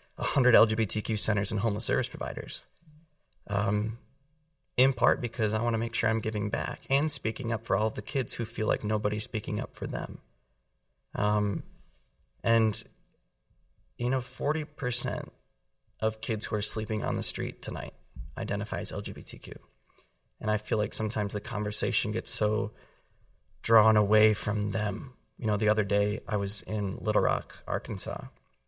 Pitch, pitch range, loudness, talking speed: 110 Hz, 105-115 Hz, -29 LUFS, 155 wpm